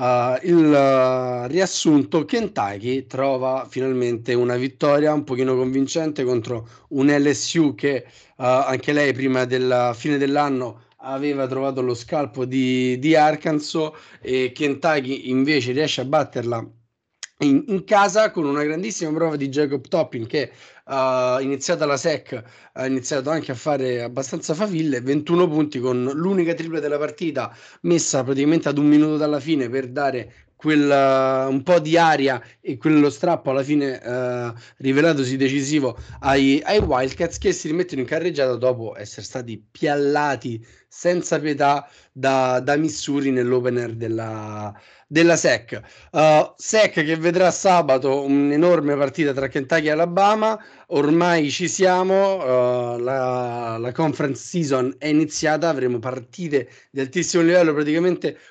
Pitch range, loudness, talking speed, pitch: 130-160 Hz, -20 LUFS, 140 wpm, 140 Hz